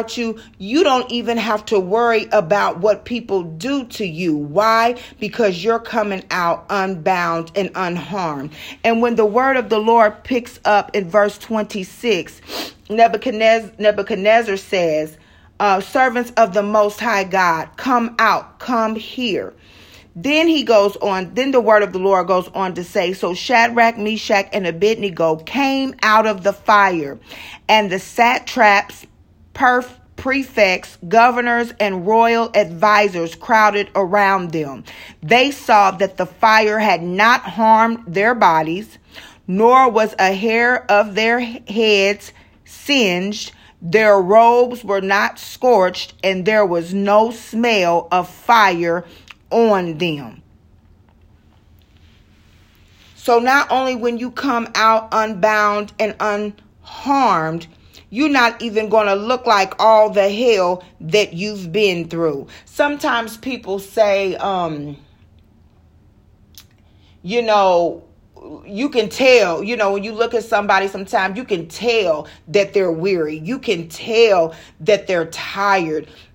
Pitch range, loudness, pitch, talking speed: 185-230 Hz, -16 LUFS, 210 Hz, 130 wpm